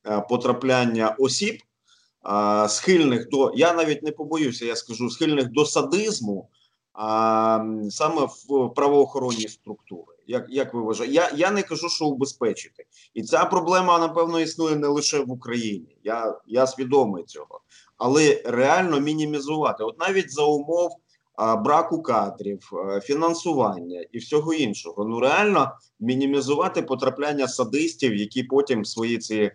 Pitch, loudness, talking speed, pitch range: 135 Hz, -23 LUFS, 125 wpm, 110-165 Hz